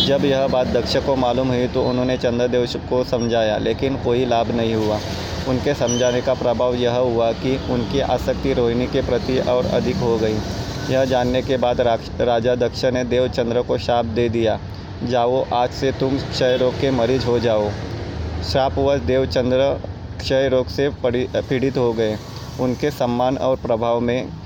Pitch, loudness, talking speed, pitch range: 125 Hz, -20 LUFS, 165 wpm, 115-130 Hz